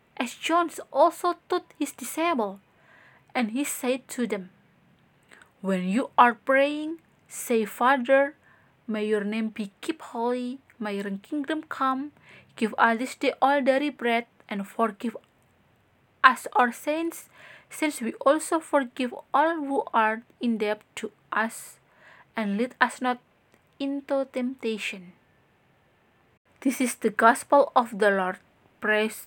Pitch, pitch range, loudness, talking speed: 250 Hz, 220-280 Hz, -26 LUFS, 130 wpm